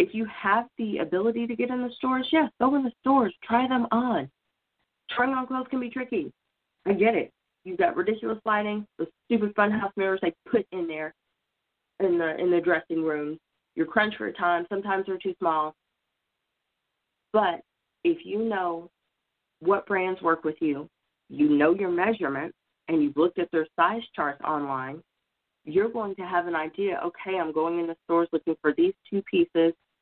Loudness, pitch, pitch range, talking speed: -26 LUFS, 190 Hz, 165-235 Hz, 190 wpm